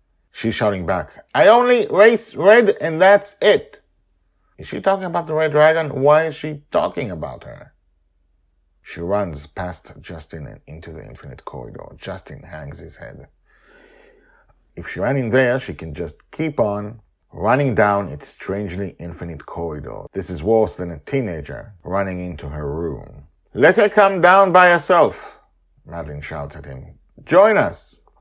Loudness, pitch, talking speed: -17 LUFS, 105 Hz, 155 wpm